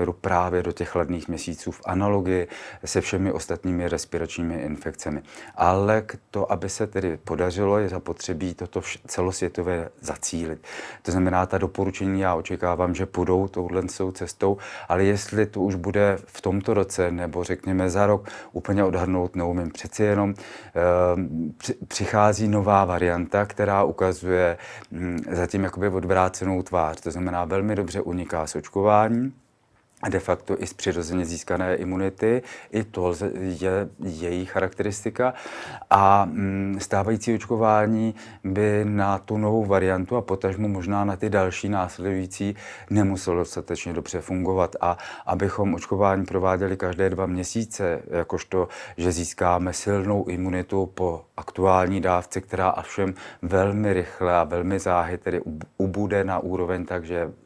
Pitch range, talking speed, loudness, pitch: 90-100 Hz, 135 wpm, -24 LUFS, 95 Hz